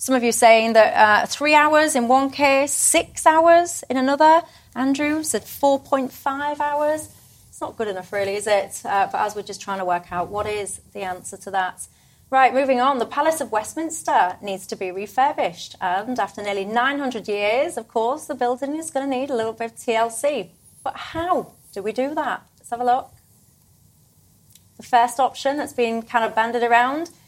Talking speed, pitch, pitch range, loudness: 195 wpm, 245 Hz, 210-280 Hz, -20 LUFS